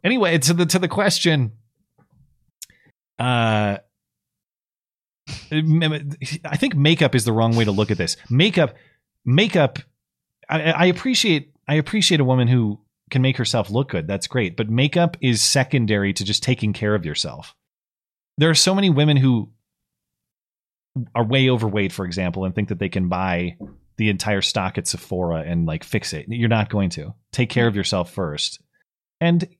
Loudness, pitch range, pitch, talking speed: -20 LUFS, 105-155 Hz, 125 Hz, 165 wpm